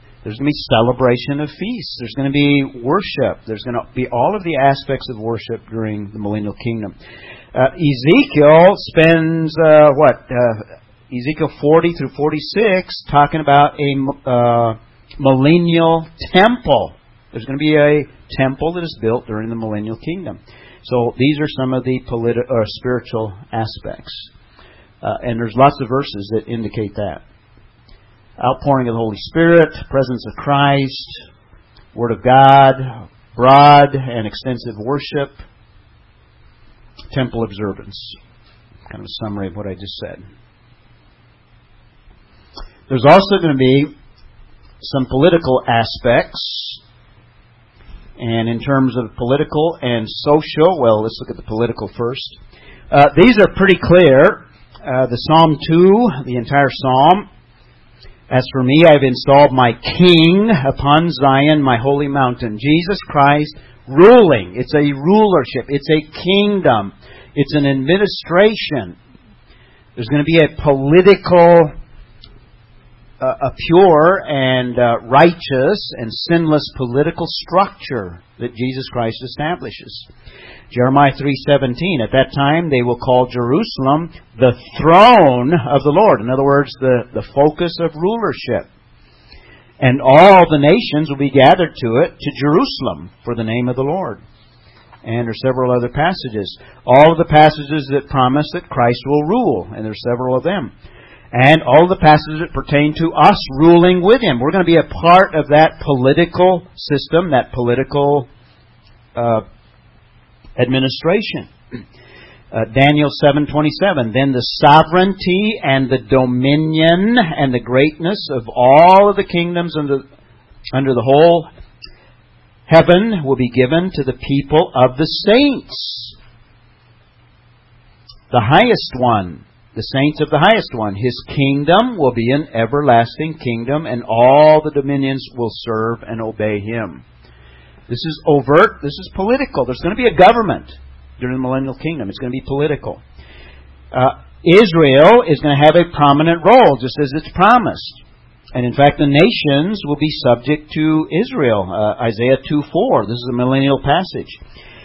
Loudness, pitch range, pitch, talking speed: -13 LUFS, 120-155 Hz, 135 Hz, 145 wpm